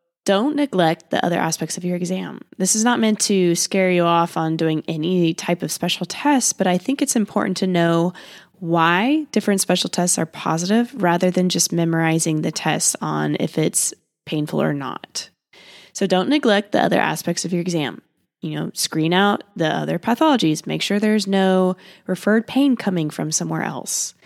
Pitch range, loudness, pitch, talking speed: 170-205 Hz, -19 LUFS, 180 Hz, 185 wpm